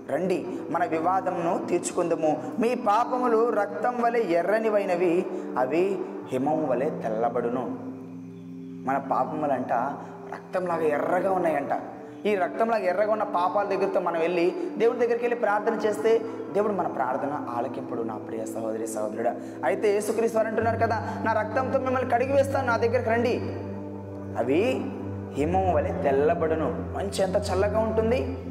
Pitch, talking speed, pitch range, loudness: 195 Hz, 120 wpm, 155-225 Hz, -26 LUFS